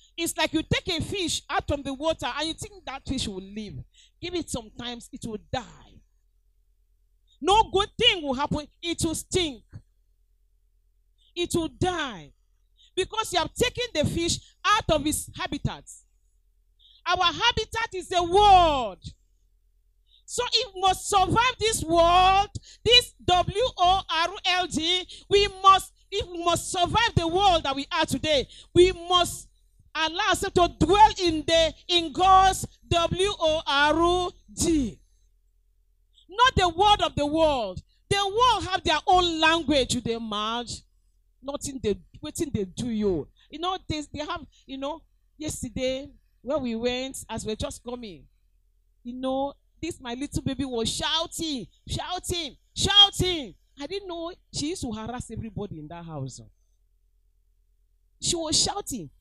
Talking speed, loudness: 140 wpm, -24 LUFS